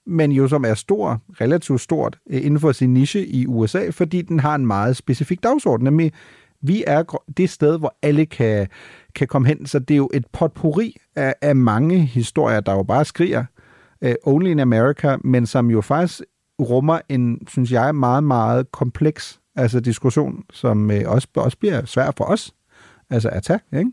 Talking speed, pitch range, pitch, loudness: 185 wpm, 120-155 Hz, 135 Hz, -19 LUFS